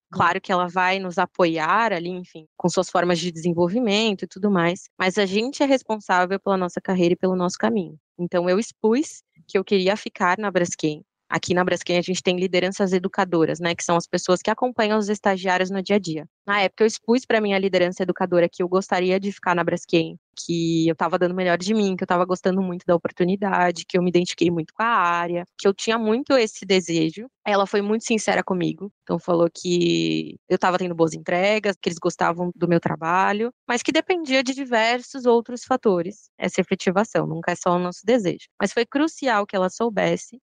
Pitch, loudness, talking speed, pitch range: 185 Hz, -22 LUFS, 210 wpm, 175-210 Hz